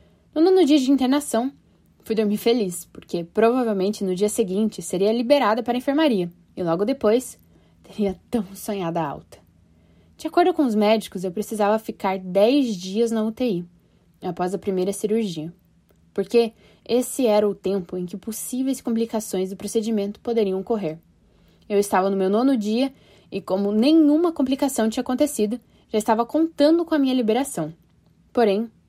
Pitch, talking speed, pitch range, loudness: 220 Hz, 155 wpm, 195-250 Hz, -22 LUFS